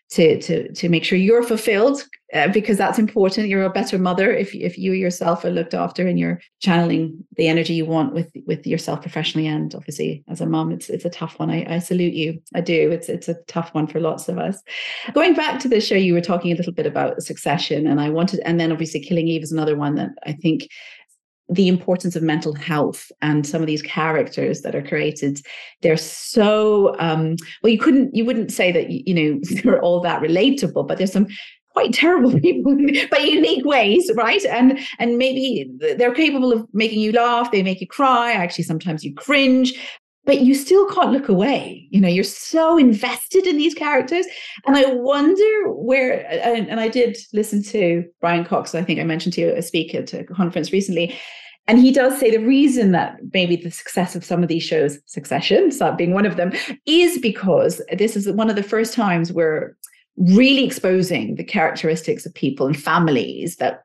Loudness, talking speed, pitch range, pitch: -18 LUFS, 205 wpm, 165-250 Hz, 195 Hz